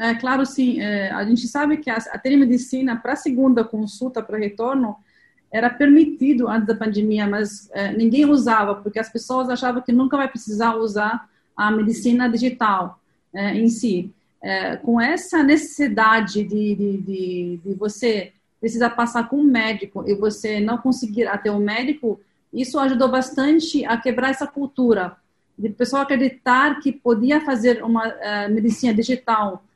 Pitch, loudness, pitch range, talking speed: 230 Hz, -20 LUFS, 210-260 Hz, 160 wpm